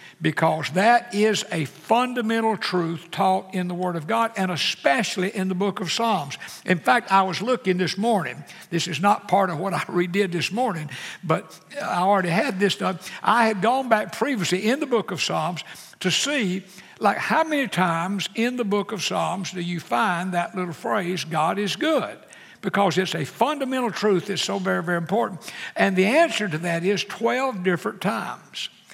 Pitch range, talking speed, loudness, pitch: 175-225 Hz, 190 wpm, -23 LUFS, 190 Hz